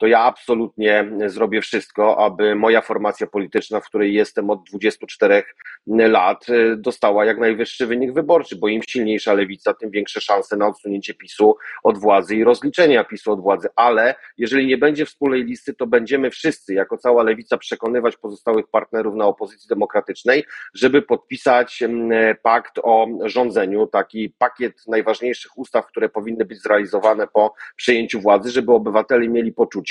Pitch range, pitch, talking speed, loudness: 105-120 Hz, 110 Hz, 150 wpm, -18 LUFS